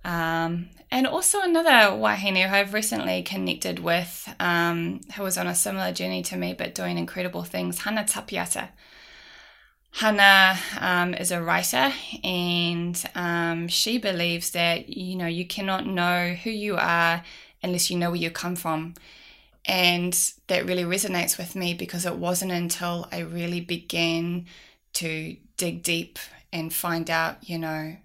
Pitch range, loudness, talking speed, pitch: 165-185 Hz, -24 LUFS, 150 wpm, 175 Hz